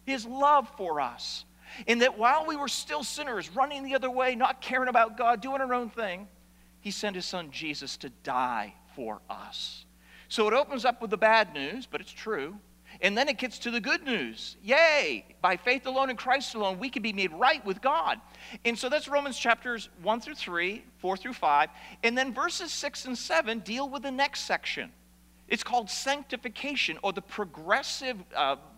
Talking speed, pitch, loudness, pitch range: 195 wpm, 240 Hz, -29 LUFS, 195-270 Hz